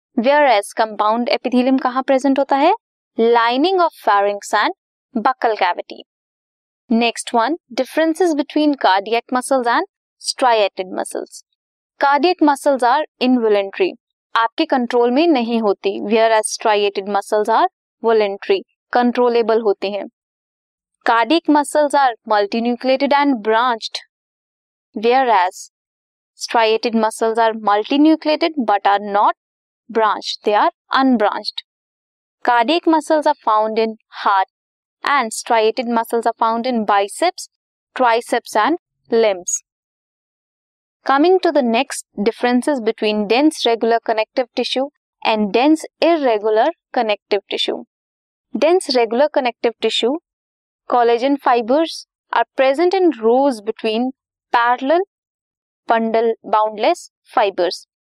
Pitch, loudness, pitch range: 240 Hz, -17 LUFS, 225-290 Hz